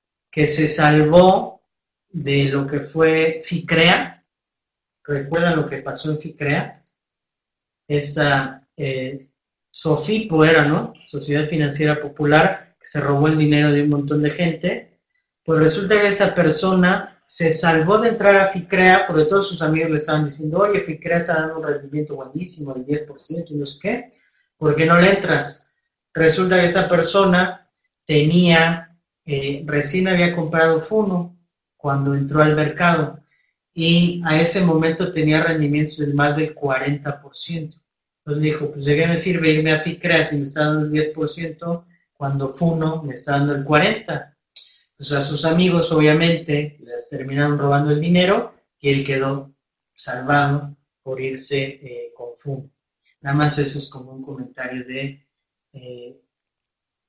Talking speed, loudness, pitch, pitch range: 150 wpm, -18 LUFS, 155 Hz, 145-170 Hz